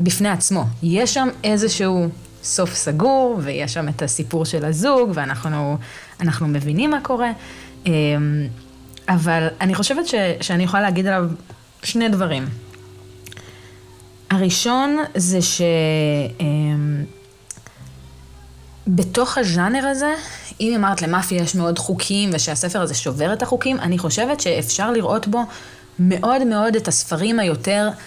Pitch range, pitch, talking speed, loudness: 150-210 Hz, 175 Hz, 115 wpm, -19 LUFS